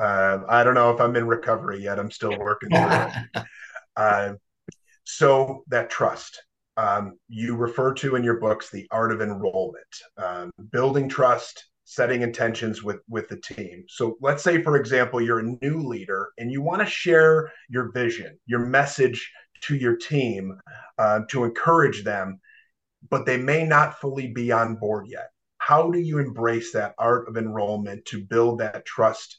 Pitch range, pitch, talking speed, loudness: 110-135 Hz, 120 Hz, 170 wpm, -23 LUFS